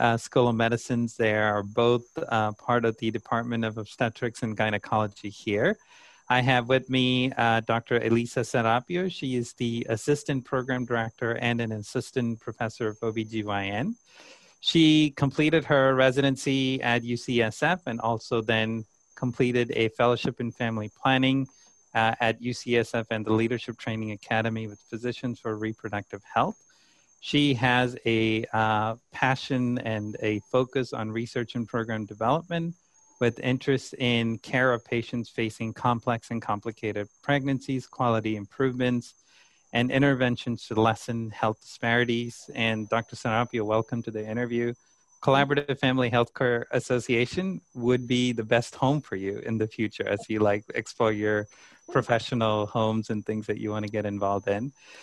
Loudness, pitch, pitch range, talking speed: -27 LUFS, 120 Hz, 110-125 Hz, 145 wpm